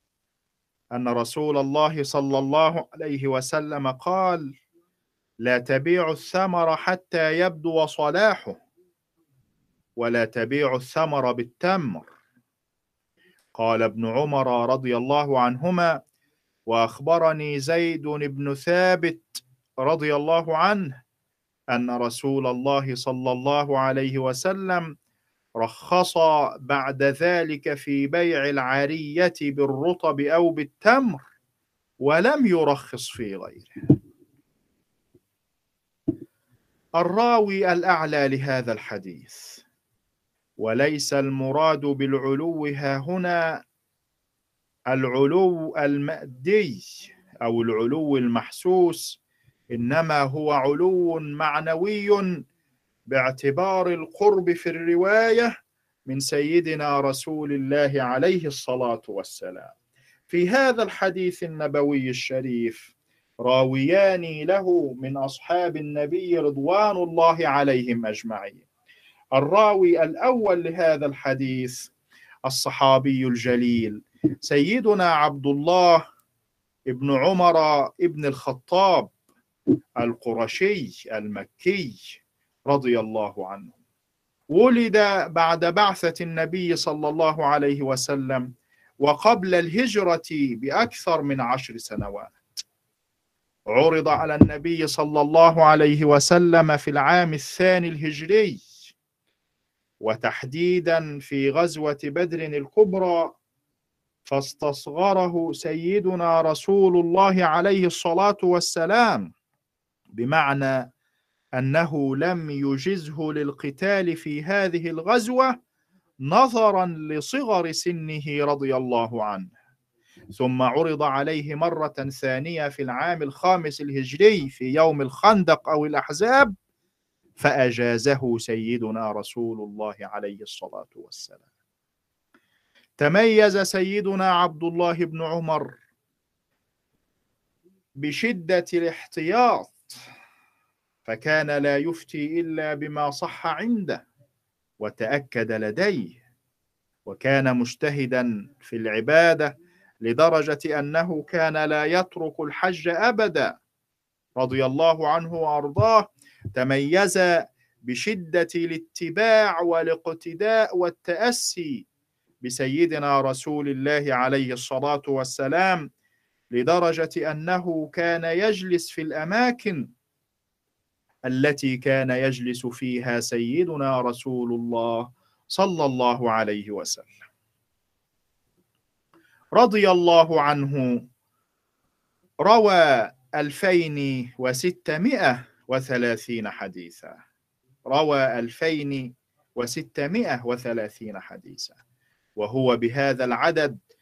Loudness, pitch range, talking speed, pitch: -22 LUFS, 130-175 Hz, 80 wpm, 150 Hz